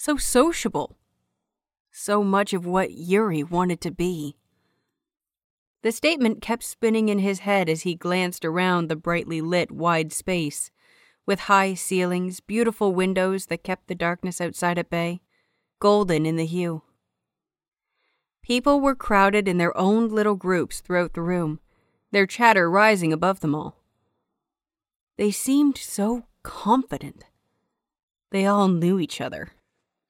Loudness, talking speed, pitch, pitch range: -23 LUFS, 135 wpm, 185 Hz, 170-210 Hz